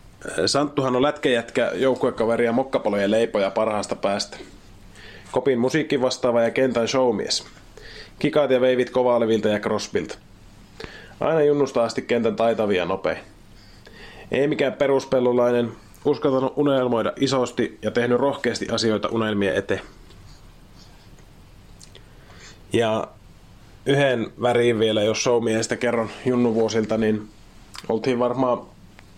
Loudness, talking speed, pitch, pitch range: -22 LUFS, 105 wpm, 120 Hz, 110-130 Hz